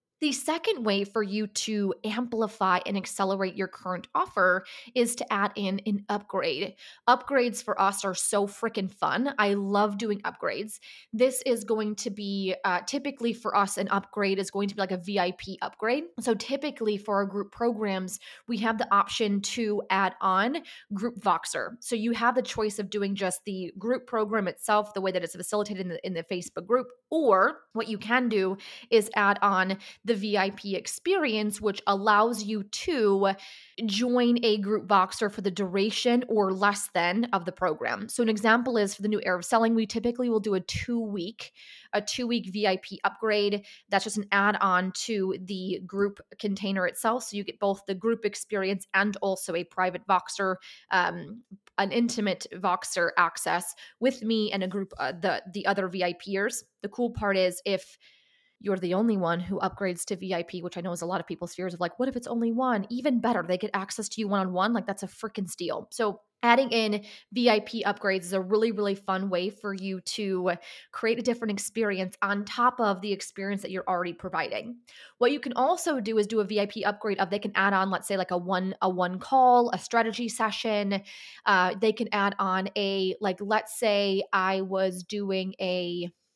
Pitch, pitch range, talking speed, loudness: 205 Hz, 190-225 Hz, 195 wpm, -28 LUFS